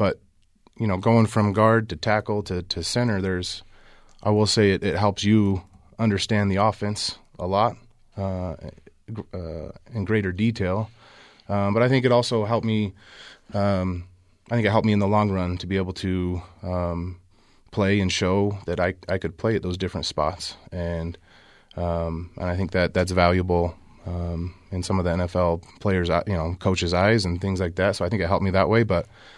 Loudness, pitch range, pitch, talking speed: -24 LUFS, 90-105 Hz, 95 Hz, 195 wpm